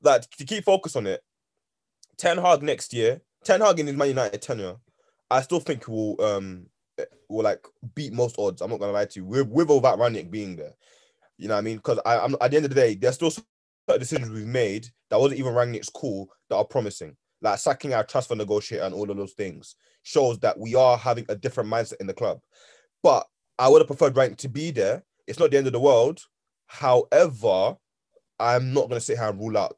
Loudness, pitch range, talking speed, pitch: -24 LUFS, 110-155 Hz, 230 wpm, 125 Hz